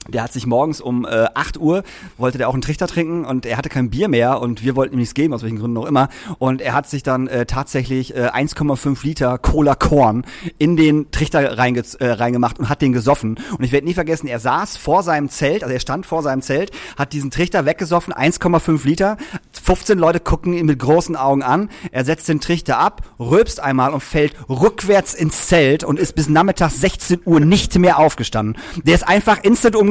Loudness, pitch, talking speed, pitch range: -17 LUFS, 145 Hz, 220 wpm, 130-165 Hz